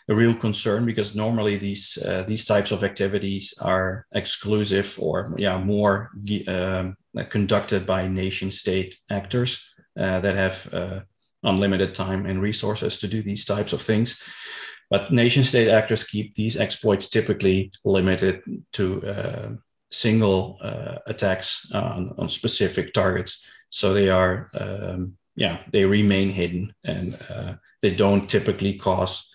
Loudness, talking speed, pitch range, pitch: -23 LUFS, 140 wpm, 95-110 Hz, 100 Hz